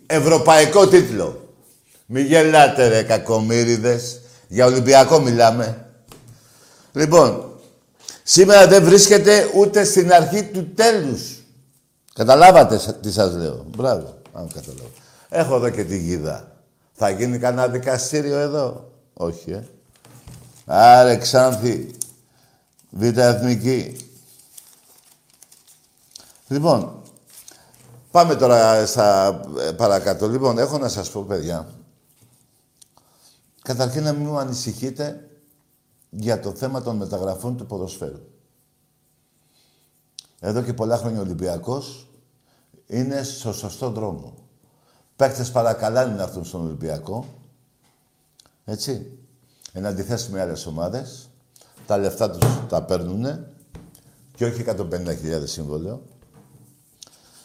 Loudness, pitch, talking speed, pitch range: -17 LUFS, 125 Hz, 95 wpm, 110-140 Hz